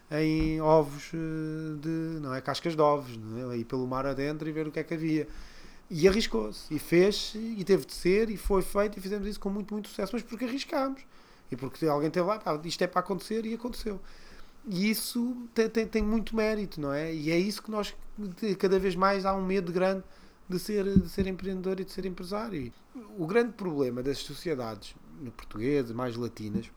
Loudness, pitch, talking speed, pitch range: -30 LUFS, 185 Hz, 205 wpm, 155-210 Hz